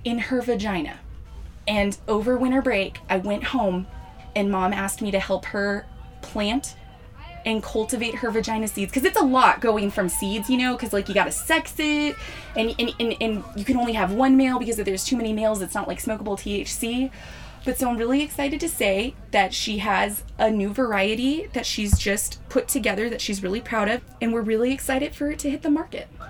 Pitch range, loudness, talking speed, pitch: 200-255 Hz, -24 LUFS, 210 wpm, 225 Hz